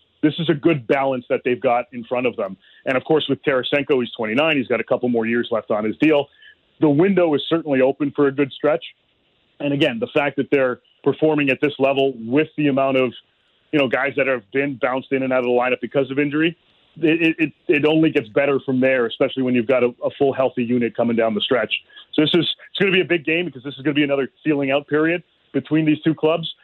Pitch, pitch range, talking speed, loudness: 140 Hz, 130-155 Hz, 255 wpm, -20 LUFS